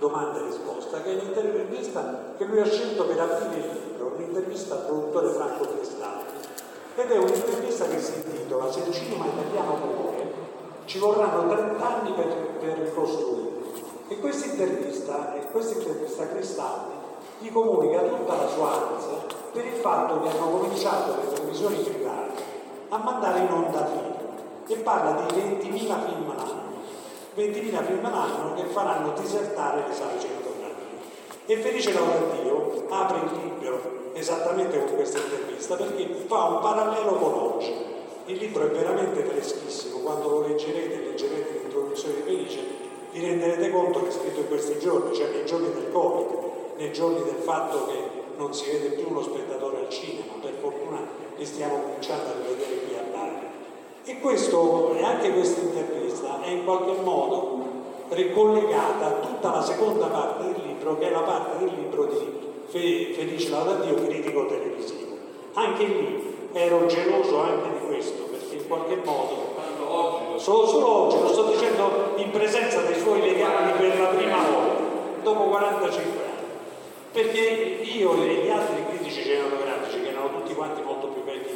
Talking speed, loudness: 155 wpm, -26 LUFS